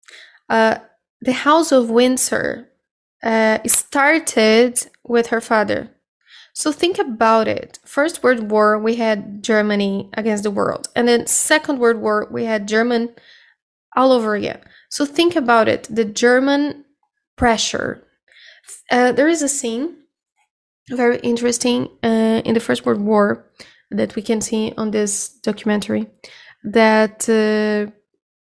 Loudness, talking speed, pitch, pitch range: -17 LUFS, 135 wpm, 230 Hz, 220-255 Hz